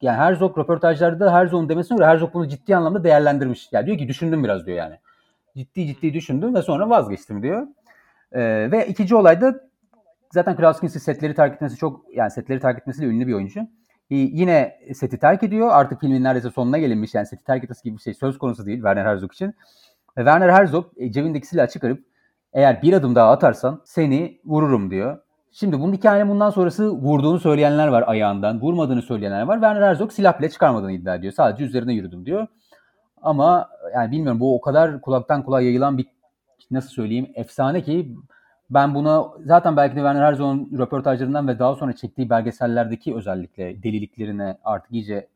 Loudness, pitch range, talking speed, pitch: -19 LUFS, 125-170 Hz, 175 wpm, 140 Hz